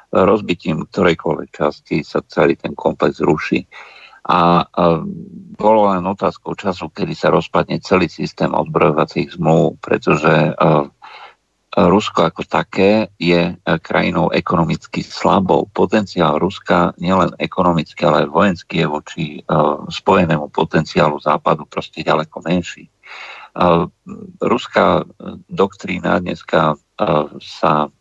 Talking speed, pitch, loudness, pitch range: 115 wpm, 85 Hz, -16 LUFS, 80-90 Hz